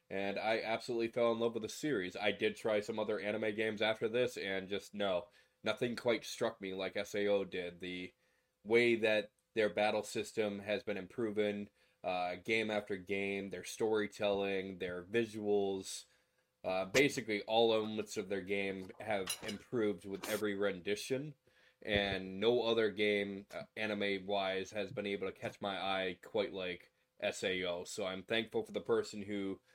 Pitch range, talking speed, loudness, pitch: 95-110 Hz, 160 wpm, -37 LUFS, 105 Hz